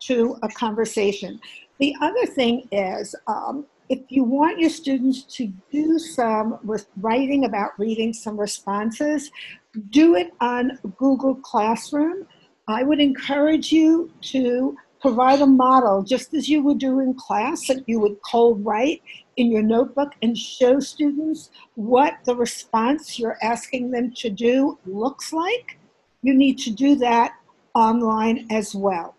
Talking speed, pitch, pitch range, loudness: 145 wpm, 255 Hz, 225-280 Hz, -21 LUFS